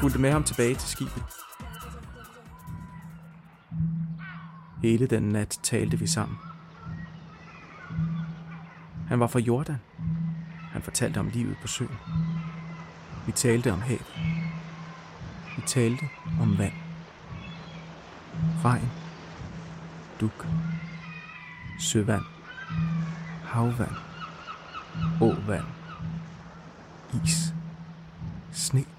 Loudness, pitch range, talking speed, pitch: -29 LUFS, 135-165 Hz, 75 wpm, 165 Hz